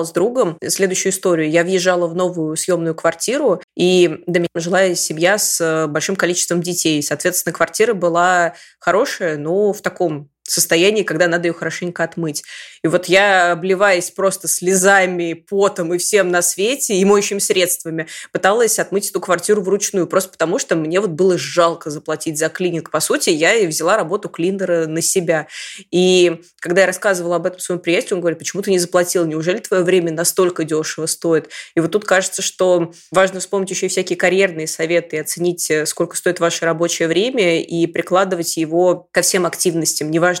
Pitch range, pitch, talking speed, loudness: 165-185 Hz, 175 Hz, 170 wpm, -16 LUFS